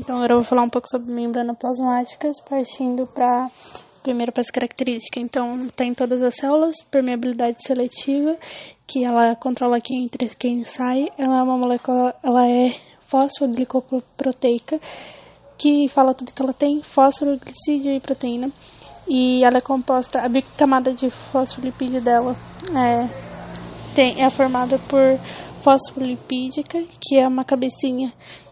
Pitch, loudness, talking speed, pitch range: 255 Hz, -20 LUFS, 140 wpm, 245-270 Hz